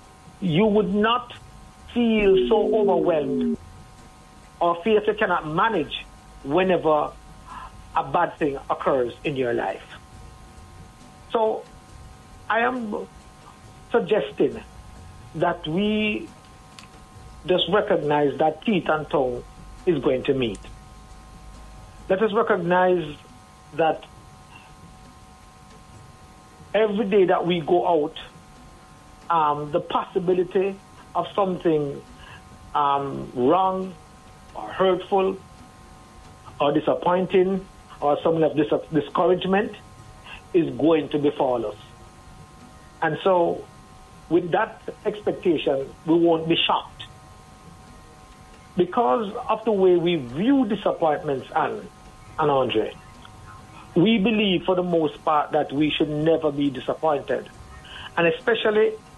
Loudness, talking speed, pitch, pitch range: -23 LUFS, 100 wpm, 170 Hz, 145-200 Hz